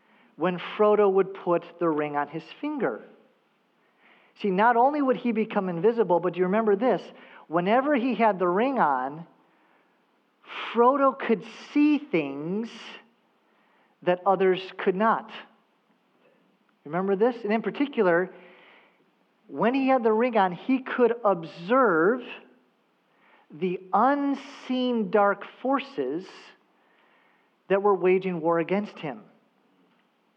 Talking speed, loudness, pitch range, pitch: 115 wpm, -25 LUFS, 185-245 Hz, 215 Hz